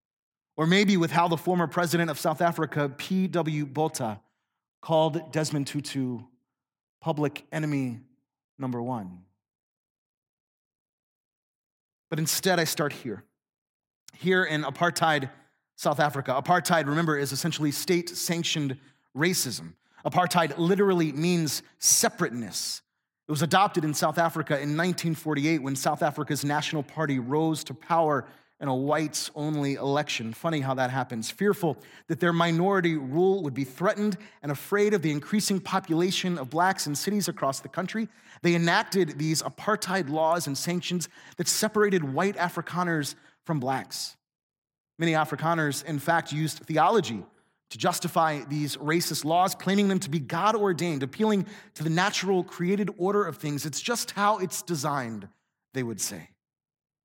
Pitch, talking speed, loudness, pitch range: 160 Hz, 140 wpm, -27 LUFS, 145-175 Hz